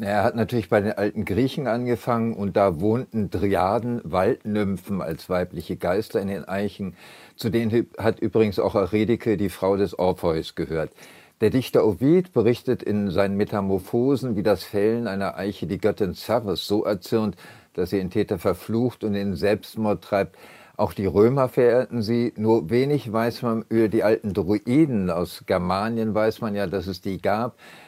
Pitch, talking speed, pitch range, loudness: 110 Hz, 170 wpm, 100-115 Hz, -23 LUFS